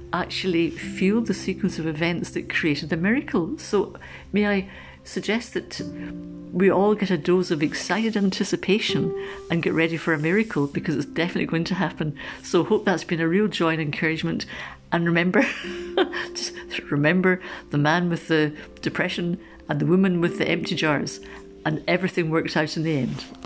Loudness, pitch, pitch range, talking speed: -24 LUFS, 175 Hz, 160-195 Hz, 170 wpm